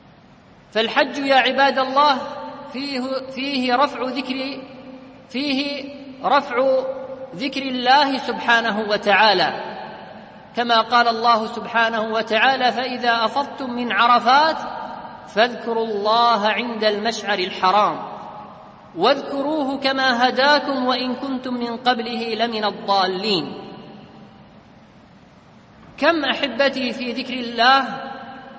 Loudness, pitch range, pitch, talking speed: -19 LUFS, 230-270 Hz, 255 Hz, 90 wpm